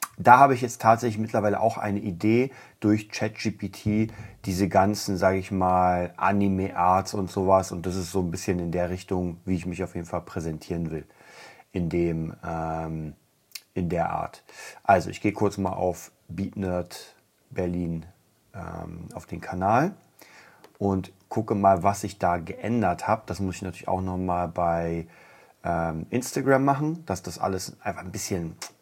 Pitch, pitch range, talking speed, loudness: 95 Hz, 90-105 Hz, 160 wpm, -26 LUFS